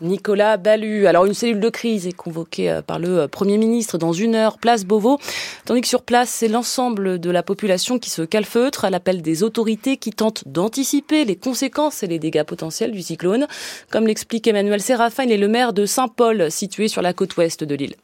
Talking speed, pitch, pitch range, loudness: 205 wpm, 215 Hz, 185-235 Hz, -19 LUFS